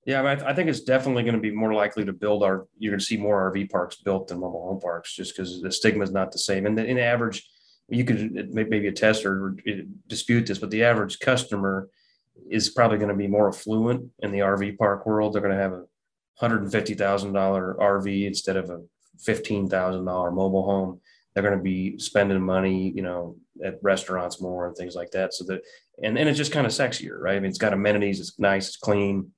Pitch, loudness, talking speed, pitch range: 100 Hz, -25 LUFS, 235 wpm, 95-110 Hz